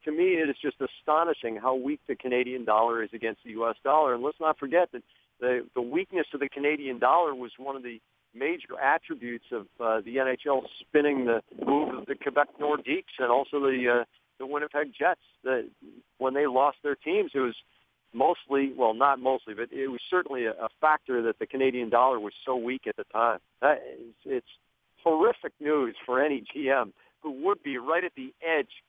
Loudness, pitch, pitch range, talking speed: -28 LUFS, 135 Hz, 120-150 Hz, 195 wpm